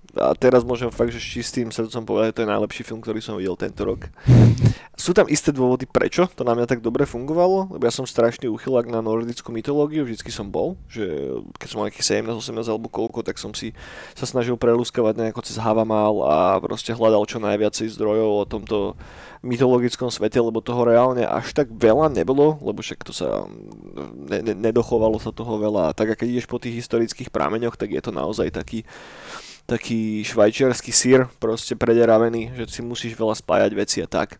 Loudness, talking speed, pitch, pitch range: -21 LUFS, 195 wpm, 115 Hz, 110-125 Hz